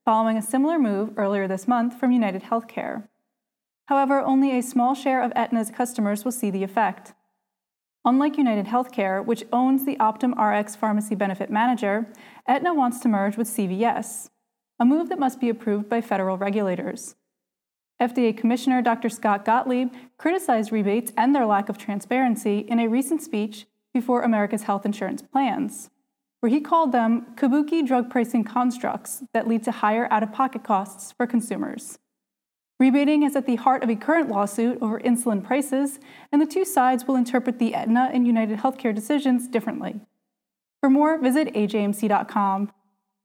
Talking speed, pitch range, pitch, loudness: 160 wpm, 215-260 Hz, 235 Hz, -23 LUFS